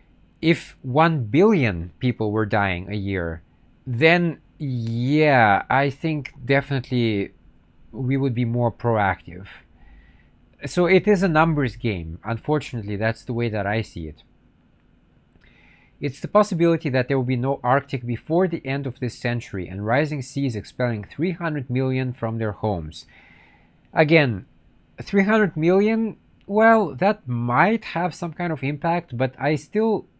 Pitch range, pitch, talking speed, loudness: 100-160 Hz, 125 Hz, 140 wpm, -22 LUFS